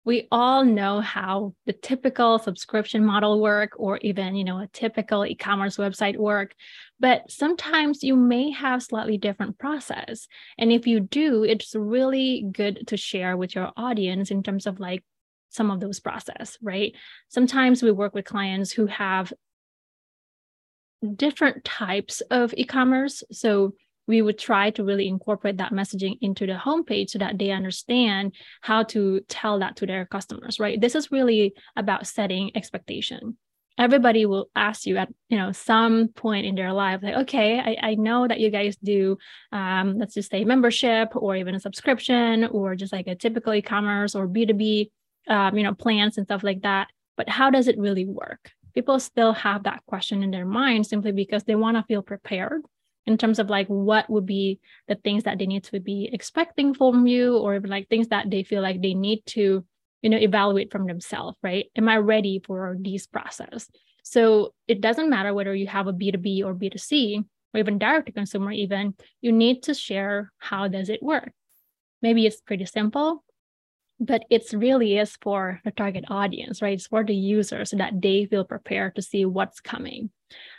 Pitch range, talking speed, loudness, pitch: 200-230 Hz, 185 wpm, -24 LUFS, 210 Hz